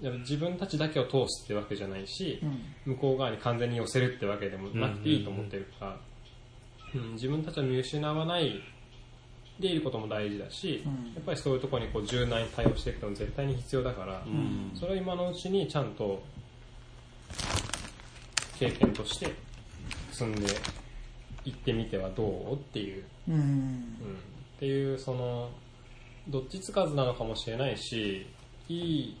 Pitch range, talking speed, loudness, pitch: 110-135 Hz, 320 characters per minute, -33 LUFS, 125 Hz